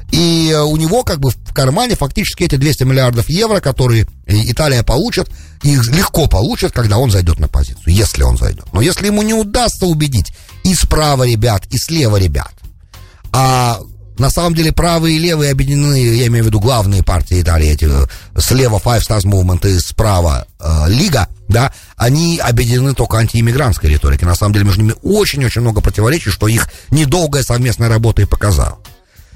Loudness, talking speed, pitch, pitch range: -13 LUFS, 170 wpm, 115 Hz, 90-140 Hz